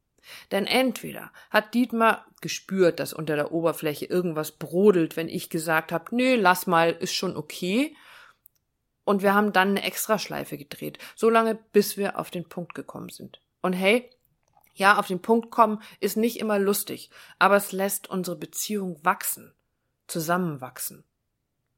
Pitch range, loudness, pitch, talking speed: 170-215 Hz, -25 LUFS, 190 Hz, 150 wpm